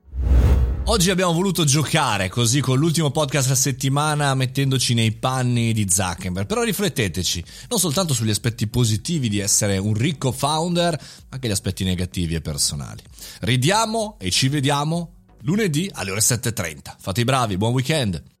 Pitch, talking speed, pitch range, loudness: 130 Hz, 155 wpm, 105-155 Hz, -20 LUFS